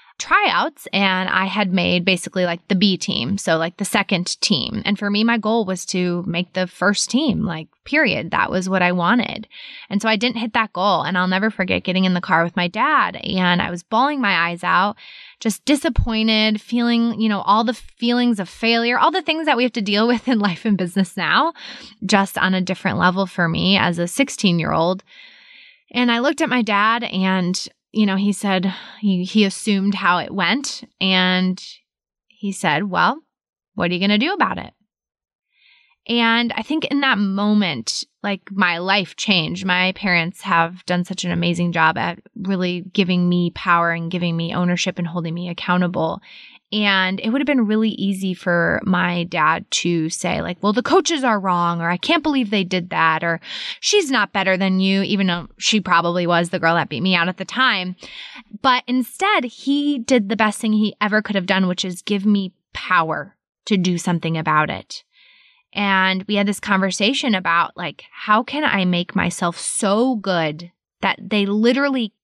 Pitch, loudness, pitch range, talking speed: 195 Hz, -19 LUFS, 180-230 Hz, 200 wpm